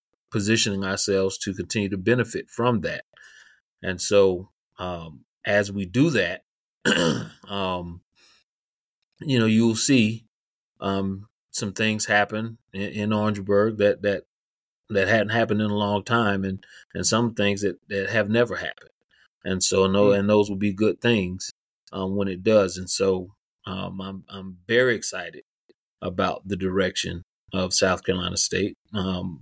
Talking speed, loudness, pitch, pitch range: 155 wpm, -23 LUFS, 100 Hz, 95-110 Hz